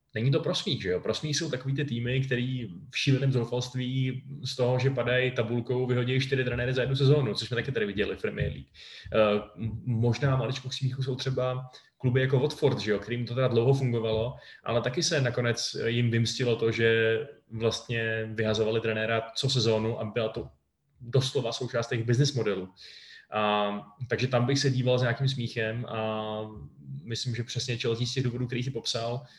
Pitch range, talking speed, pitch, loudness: 115-130 Hz, 180 wpm, 120 Hz, -28 LUFS